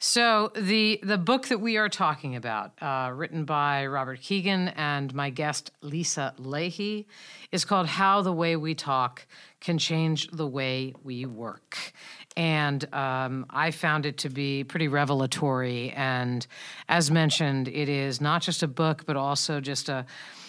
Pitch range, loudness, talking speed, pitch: 135-170 Hz, -27 LUFS, 160 wpm, 150 Hz